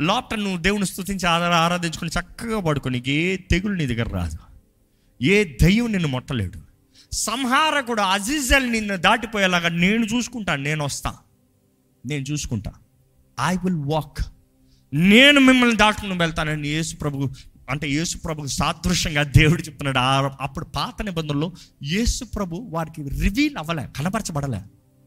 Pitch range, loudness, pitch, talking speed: 135-195 Hz, -21 LUFS, 165 Hz, 120 wpm